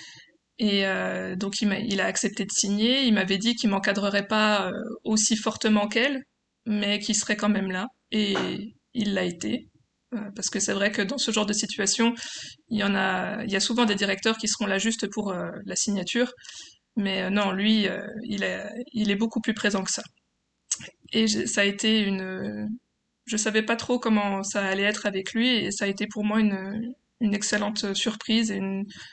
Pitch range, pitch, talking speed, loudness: 200-225 Hz, 210 Hz, 195 wpm, -25 LUFS